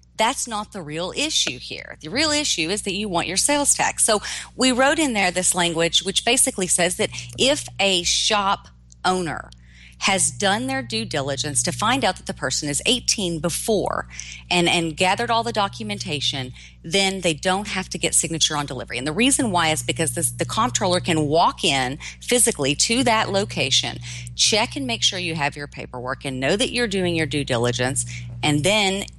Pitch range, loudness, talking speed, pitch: 135-200 Hz, -20 LUFS, 195 wpm, 170 Hz